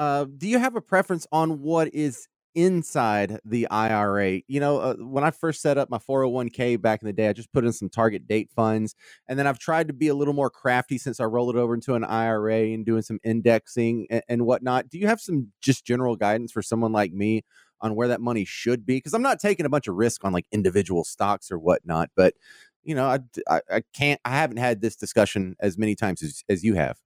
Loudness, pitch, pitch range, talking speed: -24 LUFS, 120 Hz, 110-145 Hz, 240 wpm